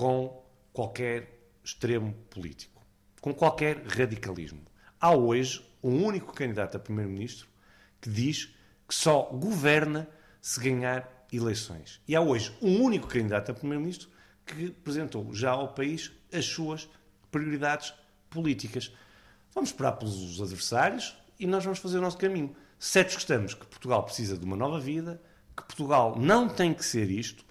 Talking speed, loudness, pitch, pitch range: 145 wpm, -29 LUFS, 130 Hz, 105-155 Hz